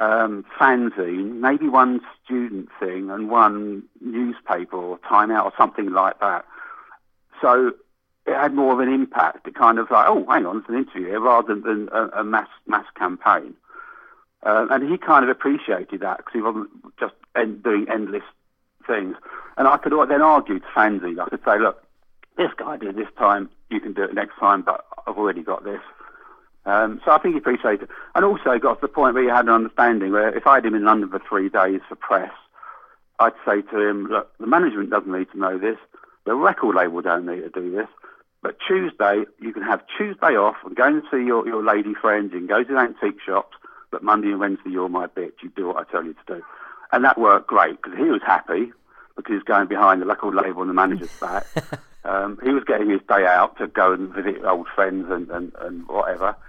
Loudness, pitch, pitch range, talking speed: -20 LUFS, 110 Hz, 95-135 Hz, 215 wpm